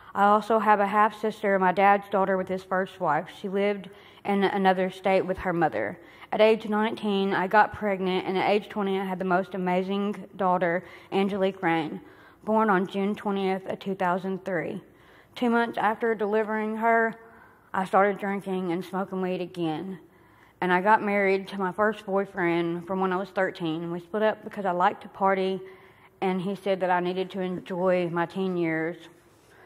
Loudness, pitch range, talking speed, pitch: -26 LUFS, 185-205 Hz, 180 wpm, 190 Hz